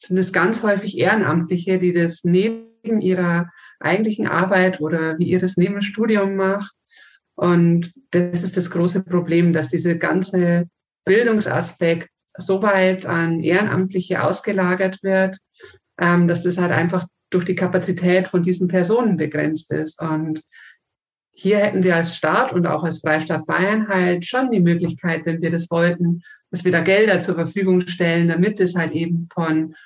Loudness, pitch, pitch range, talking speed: -19 LUFS, 180 Hz, 170-190 Hz, 155 wpm